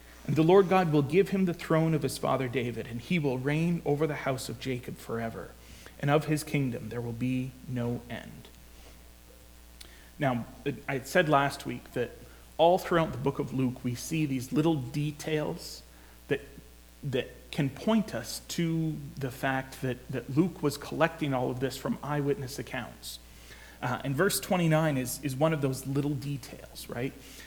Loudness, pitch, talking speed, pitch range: -30 LUFS, 135 Hz, 175 wpm, 120-155 Hz